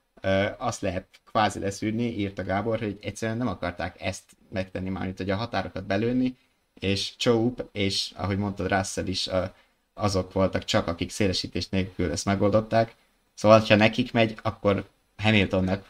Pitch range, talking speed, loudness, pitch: 95-110 Hz, 150 wpm, -26 LUFS, 100 Hz